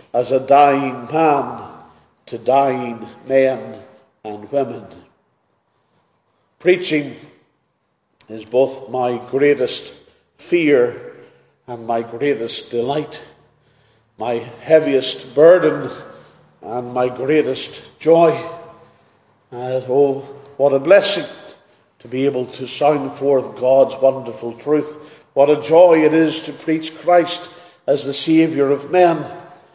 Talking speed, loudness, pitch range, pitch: 105 wpm, -16 LUFS, 125-160 Hz, 140 Hz